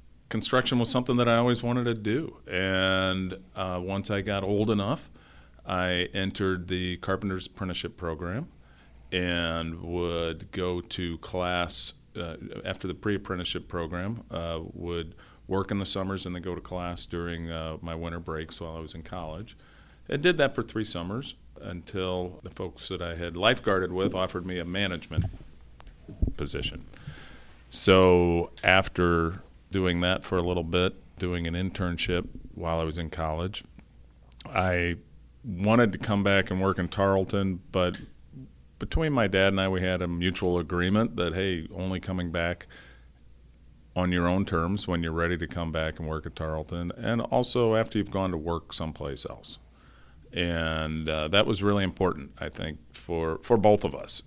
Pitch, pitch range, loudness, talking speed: 90 Hz, 80-95 Hz, -28 LUFS, 165 wpm